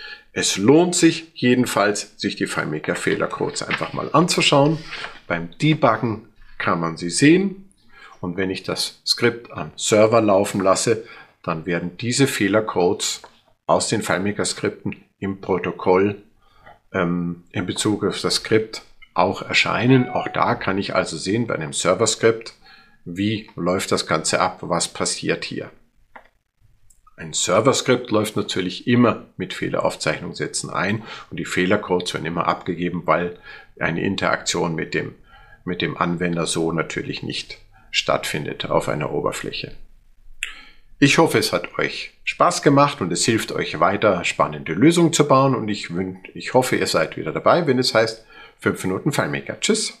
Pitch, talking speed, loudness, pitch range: 105 Hz, 145 wpm, -20 LUFS, 90-140 Hz